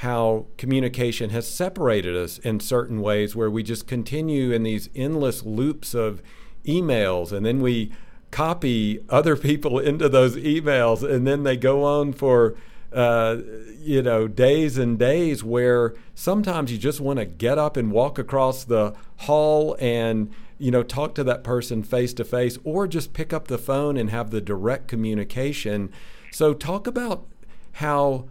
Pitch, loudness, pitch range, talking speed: 125 Hz, -23 LUFS, 115-145 Hz, 165 wpm